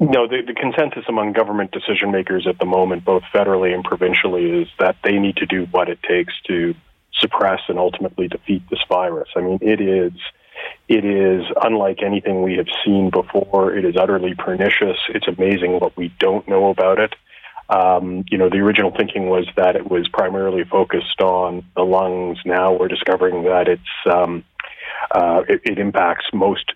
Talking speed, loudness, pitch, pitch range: 180 wpm, -18 LUFS, 95 Hz, 90-100 Hz